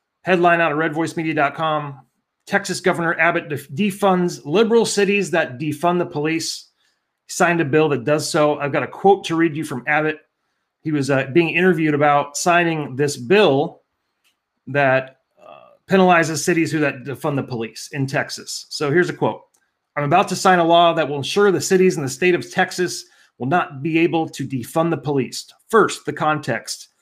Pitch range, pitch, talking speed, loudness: 145-175 Hz, 160 Hz, 180 wpm, -19 LUFS